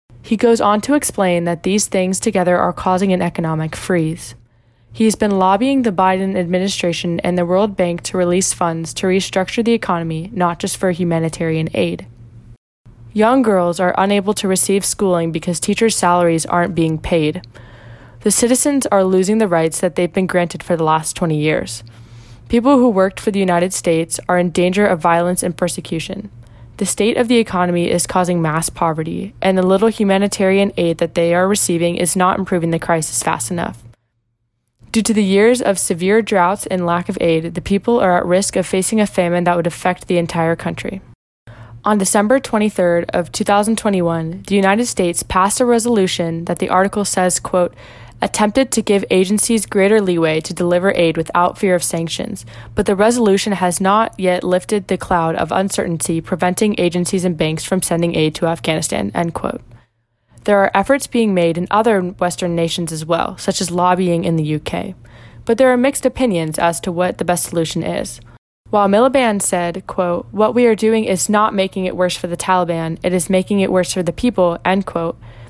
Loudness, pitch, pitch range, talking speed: -16 LUFS, 180 Hz, 165-200 Hz, 190 wpm